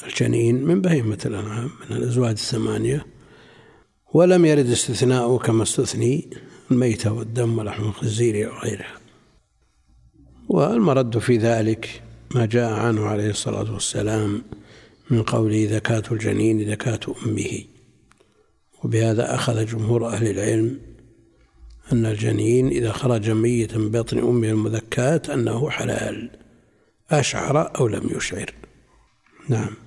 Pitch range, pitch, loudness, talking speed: 110-120 Hz, 115 Hz, -21 LUFS, 105 wpm